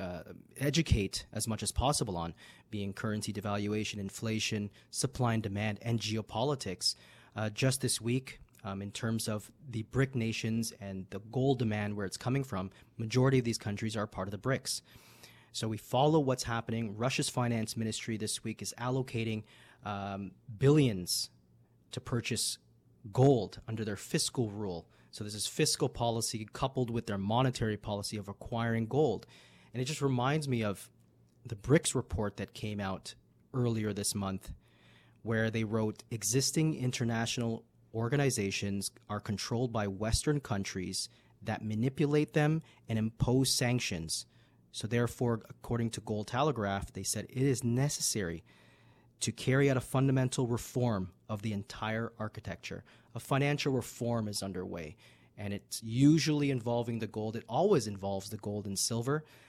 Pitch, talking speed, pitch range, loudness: 115 Hz, 150 wpm, 105-125 Hz, -33 LUFS